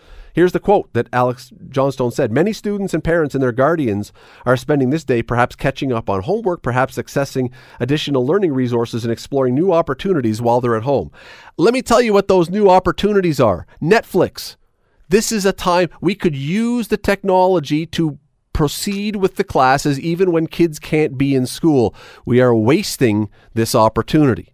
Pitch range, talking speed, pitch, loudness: 125-185 Hz, 175 wpm, 145 Hz, -17 LUFS